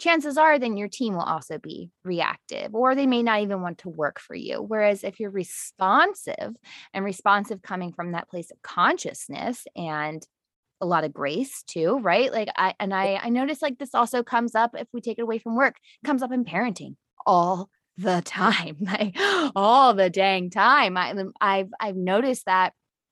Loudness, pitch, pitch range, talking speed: -24 LUFS, 210 Hz, 185-250 Hz, 190 wpm